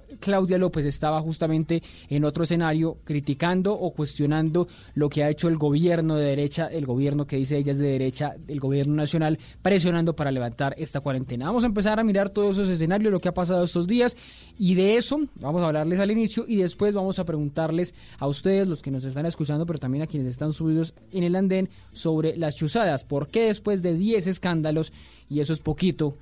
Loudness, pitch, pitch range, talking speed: -25 LUFS, 160 Hz, 145-185 Hz, 205 wpm